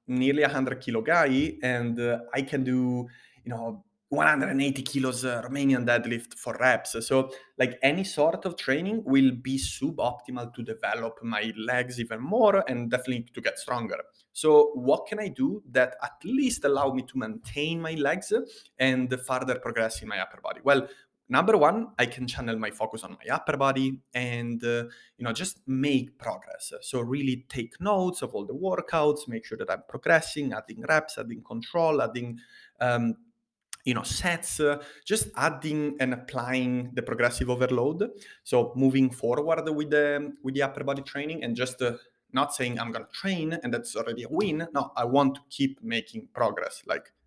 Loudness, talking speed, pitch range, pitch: -28 LUFS, 180 wpm, 120-155 Hz, 130 Hz